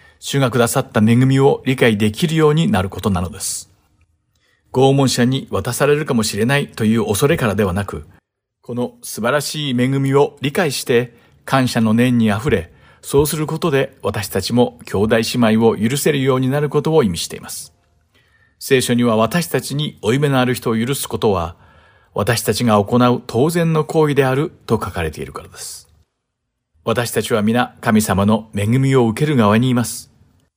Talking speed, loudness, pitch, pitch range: 335 characters per minute, -17 LUFS, 120 Hz, 110-140 Hz